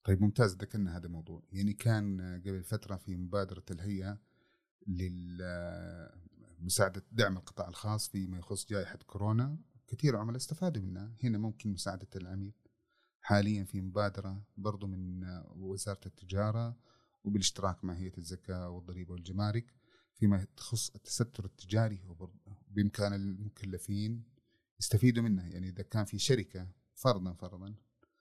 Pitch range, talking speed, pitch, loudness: 95-110 Hz, 120 wpm, 100 Hz, -36 LUFS